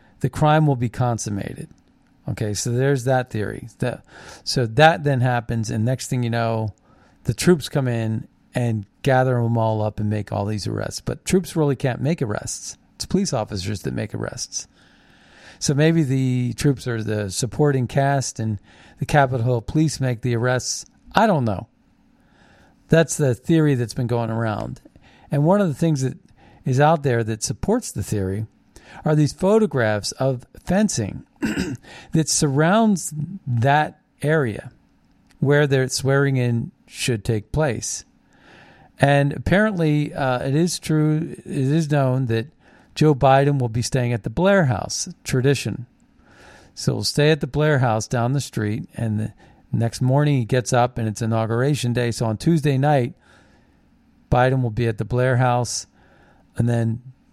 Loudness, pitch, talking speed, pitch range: -21 LUFS, 130 Hz, 160 wpm, 115-150 Hz